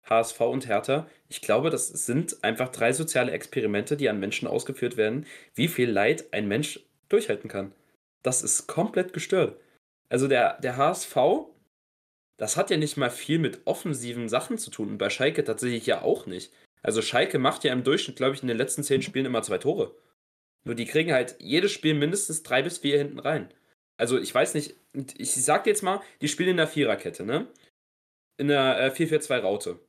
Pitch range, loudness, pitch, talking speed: 125-160 Hz, -26 LUFS, 145 Hz, 195 wpm